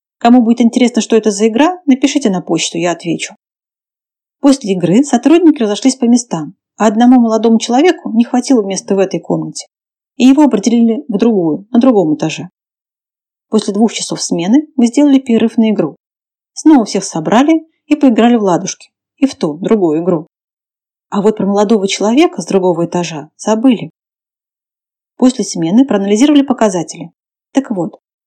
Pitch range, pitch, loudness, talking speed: 195-260 Hz, 225 Hz, -12 LUFS, 155 wpm